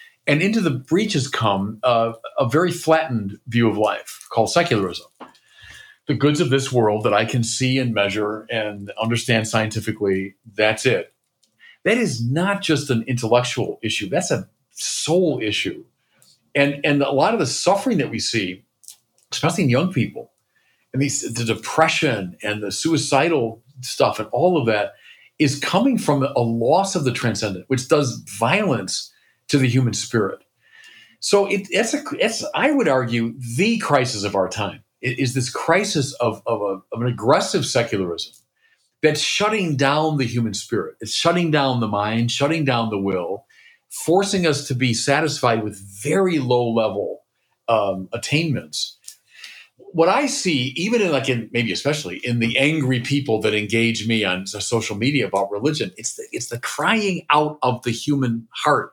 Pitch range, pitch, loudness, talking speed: 115-155 Hz, 130 Hz, -20 LUFS, 165 wpm